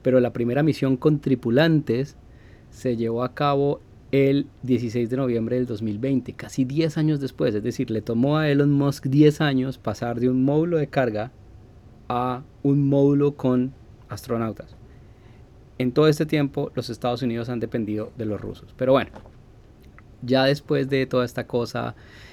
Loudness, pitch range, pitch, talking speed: -23 LUFS, 115-140 Hz, 125 Hz, 160 wpm